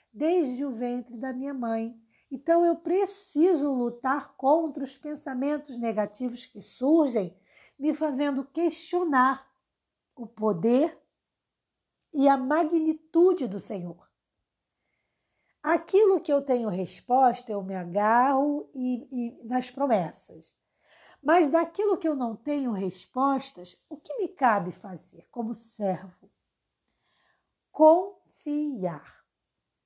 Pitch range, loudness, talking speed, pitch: 230-310 Hz, -26 LUFS, 105 wpm, 265 Hz